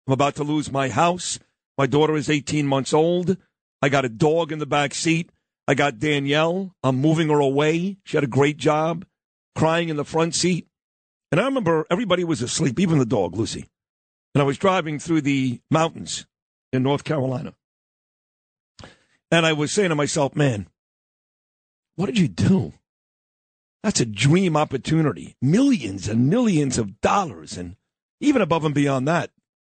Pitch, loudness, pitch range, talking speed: 150 Hz, -21 LUFS, 140-165 Hz, 165 wpm